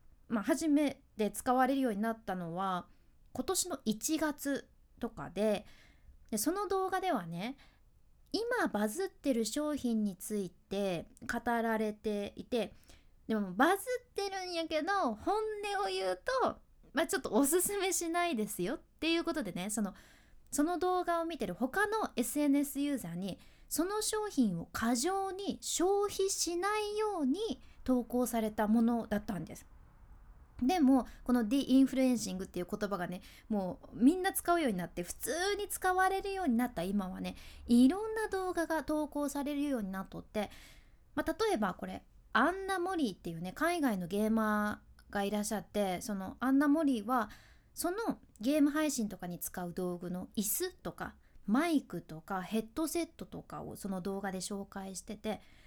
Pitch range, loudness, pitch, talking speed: 205-335 Hz, -34 LUFS, 255 Hz, 320 characters per minute